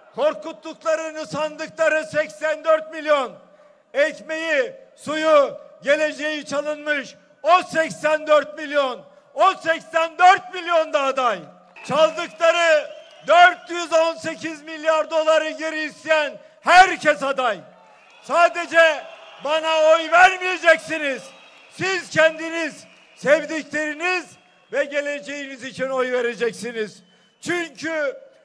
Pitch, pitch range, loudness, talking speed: 310 Hz, 290-325 Hz, -20 LUFS, 80 wpm